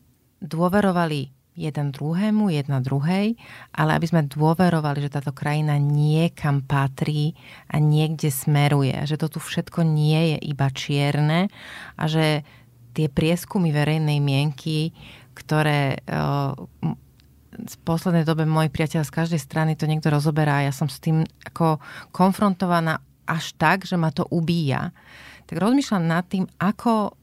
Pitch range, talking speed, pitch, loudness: 145-170 Hz, 135 wpm, 155 Hz, -22 LUFS